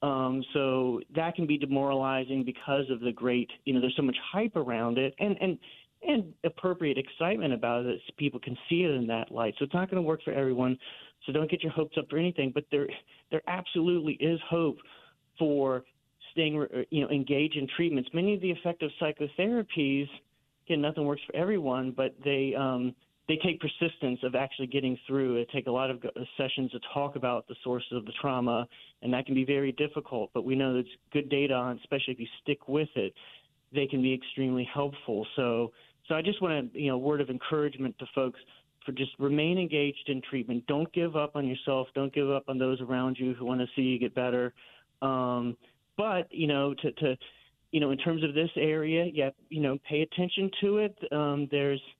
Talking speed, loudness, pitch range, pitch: 210 wpm, -31 LUFS, 130-155 Hz, 140 Hz